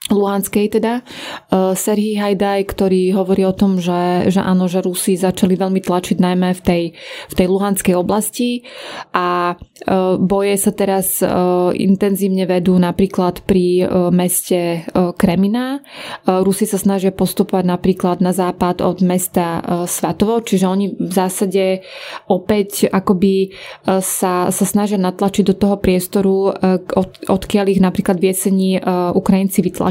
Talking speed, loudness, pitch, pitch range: 130 wpm, -16 LUFS, 190 Hz, 185-200 Hz